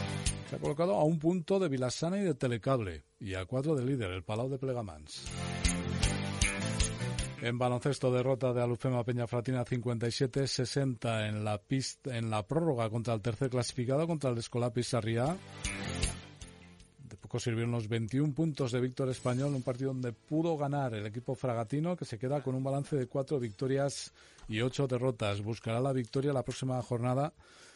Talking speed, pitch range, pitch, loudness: 165 wpm, 115-135 Hz, 125 Hz, -34 LUFS